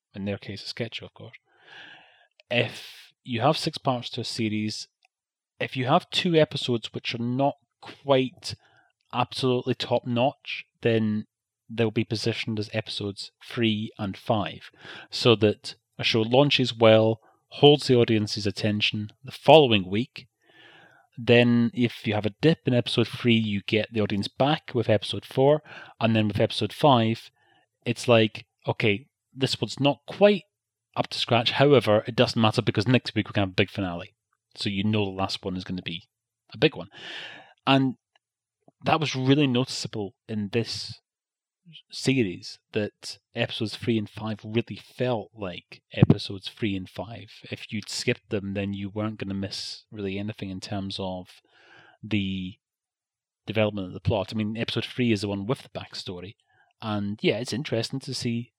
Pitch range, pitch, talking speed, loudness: 105-125 Hz, 115 Hz, 170 wpm, -25 LUFS